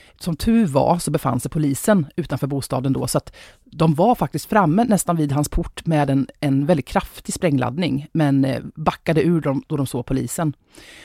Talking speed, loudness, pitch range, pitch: 185 wpm, -20 LUFS, 140-175 Hz, 155 Hz